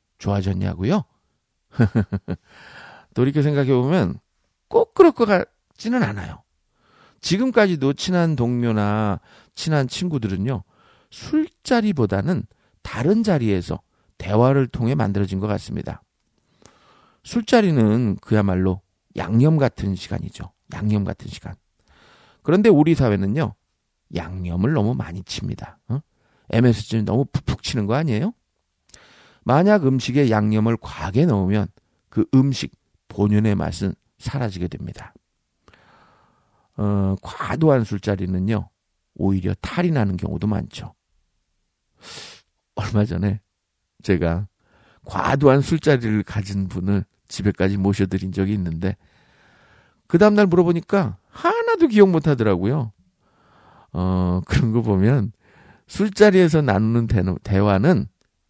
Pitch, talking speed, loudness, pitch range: 110 Hz, 245 characters per minute, -20 LUFS, 95-140 Hz